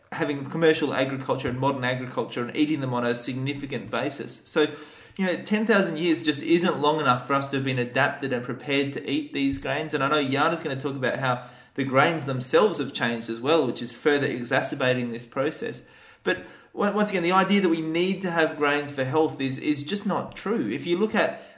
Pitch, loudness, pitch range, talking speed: 145 Hz, -25 LUFS, 130-160 Hz, 215 wpm